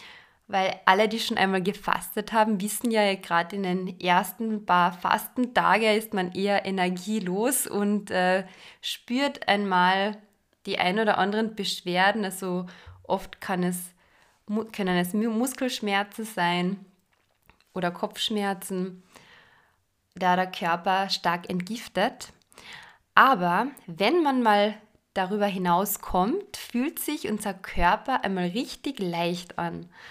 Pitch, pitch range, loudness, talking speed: 200 Hz, 185-220 Hz, -26 LUFS, 115 wpm